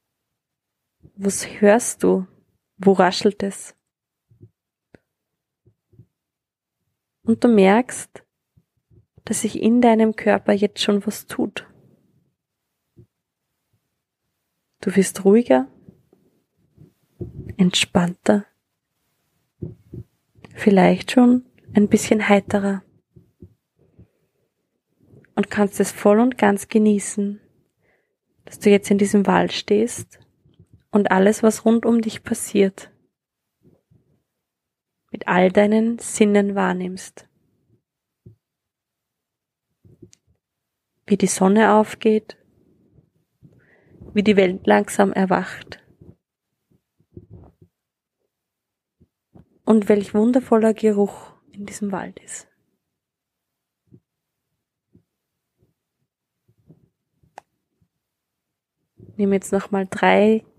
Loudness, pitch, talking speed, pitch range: -19 LUFS, 205 Hz, 75 wpm, 195-220 Hz